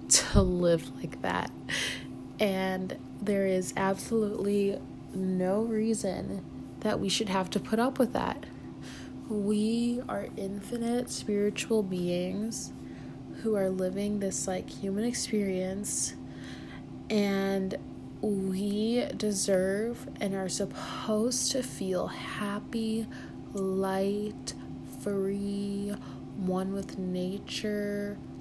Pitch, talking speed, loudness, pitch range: 200 Hz, 95 wpm, -31 LUFS, 190-220 Hz